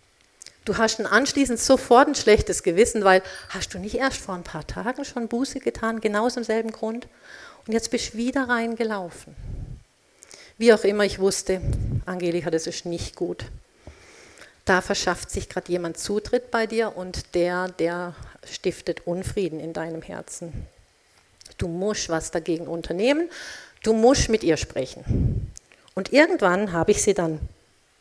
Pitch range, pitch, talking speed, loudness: 175-230 Hz, 205 Hz, 150 wpm, -23 LUFS